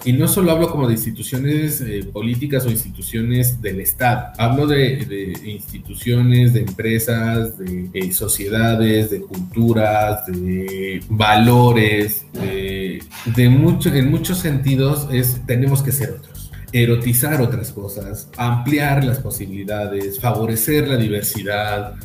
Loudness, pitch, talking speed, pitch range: -18 LUFS, 115 Hz, 120 wpm, 105-130 Hz